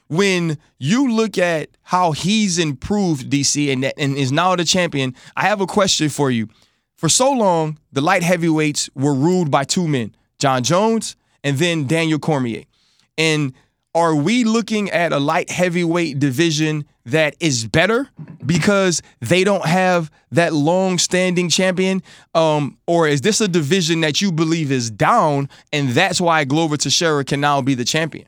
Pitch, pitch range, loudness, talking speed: 160 Hz, 140-180 Hz, -17 LUFS, 165 wpm